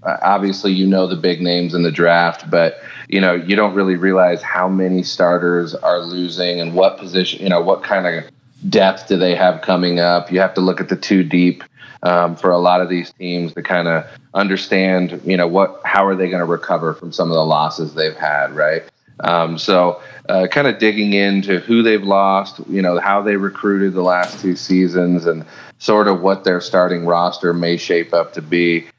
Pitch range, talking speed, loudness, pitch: 85-95 Hz, 215 wpm, -16 LUFS, 90 Hz